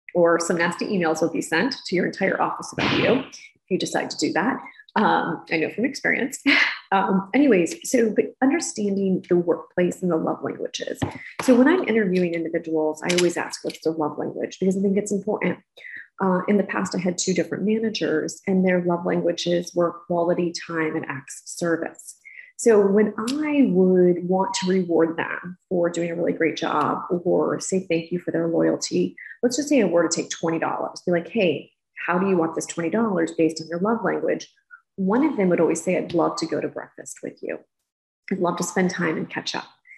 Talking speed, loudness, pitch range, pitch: 205 wpm, -23 LUFS, 165-210 Hz, 180 Hz